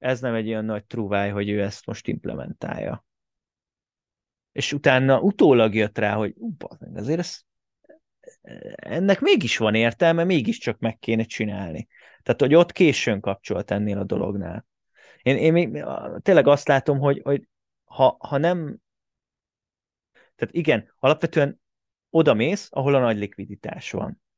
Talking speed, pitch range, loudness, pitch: 140 wpm, 105-160 Hz, -22 LUFS, 120 Hz